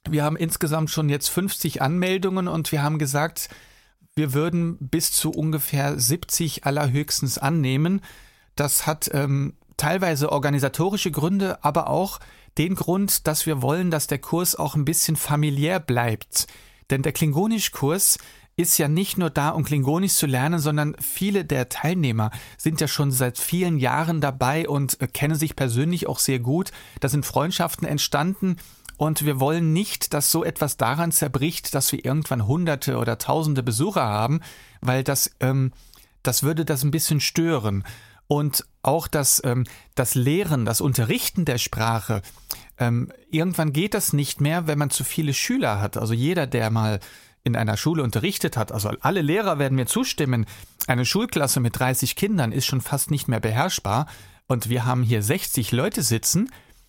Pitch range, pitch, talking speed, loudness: 130-165 Hz, 145 Hz, 165 wpm, -23 LUFS